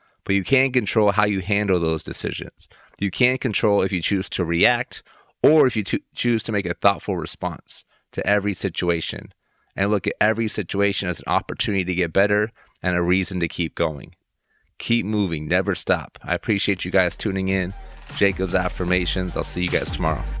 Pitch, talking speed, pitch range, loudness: 95 Hz, 190 wpm, 90-105 Hz, -22 LUFS